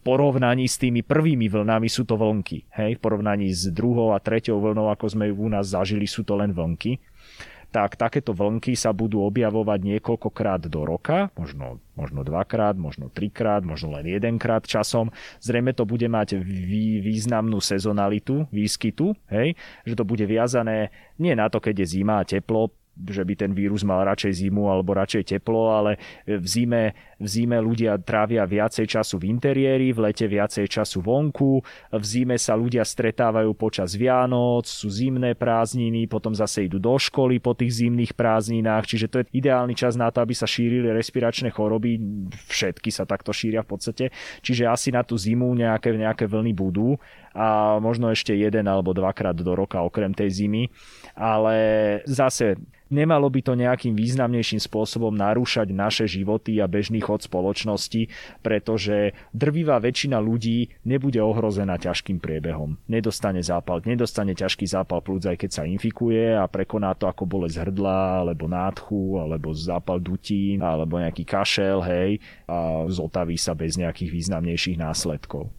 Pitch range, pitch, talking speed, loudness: 95-115 Hz, 110 Hz, 160 wpm, -23 LUFS